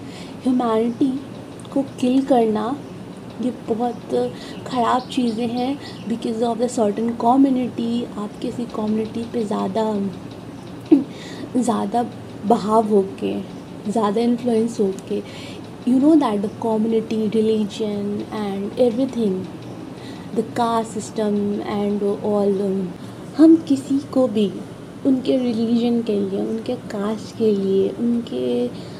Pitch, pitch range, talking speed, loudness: 230 Hz, 210-245 Hz, 110 wpm, -21 LUFS